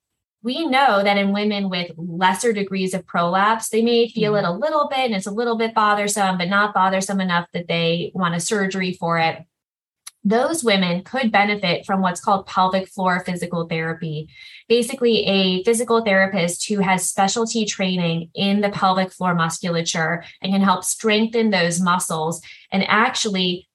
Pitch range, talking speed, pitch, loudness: 175-215 Hz, 165 wpm, 195 Hz, -20 LUFS